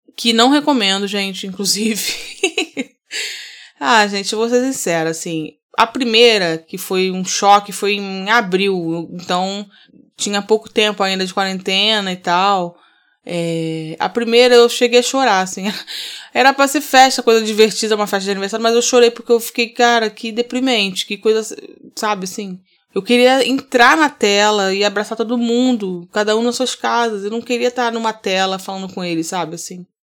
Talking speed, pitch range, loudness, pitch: 170 wpm, 190-240 Hz, -15 LUFS, 215 Hz